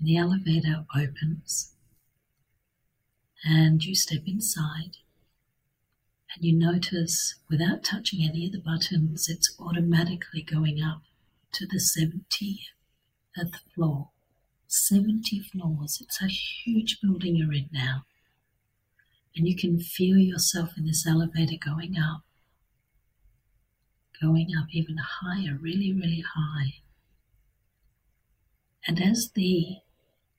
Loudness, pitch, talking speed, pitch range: -27 LUFS, 160 Hz, 105 wpm, 130-175 Hz